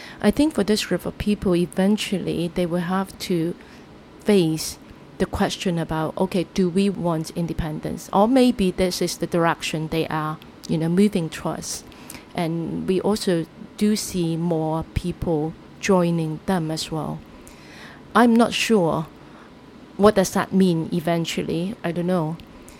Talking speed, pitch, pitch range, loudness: 145 wpm, 180 Hz, 165-195 Hz, -22 LUFS